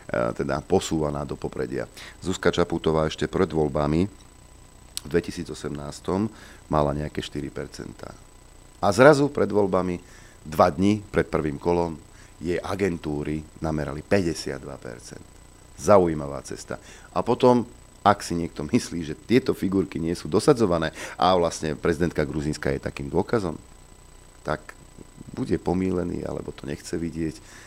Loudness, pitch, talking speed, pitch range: -25 LUFS, 85 Hz, 120 wpm, 75-100 Hz